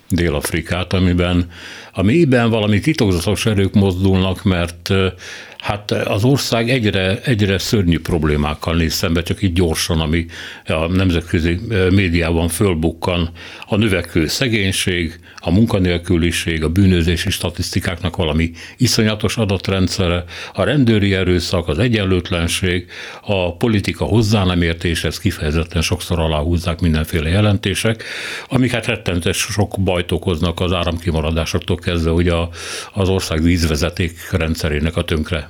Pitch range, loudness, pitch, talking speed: 85-100 Hz, -17 LUFS, 90 Hz, 115 wpm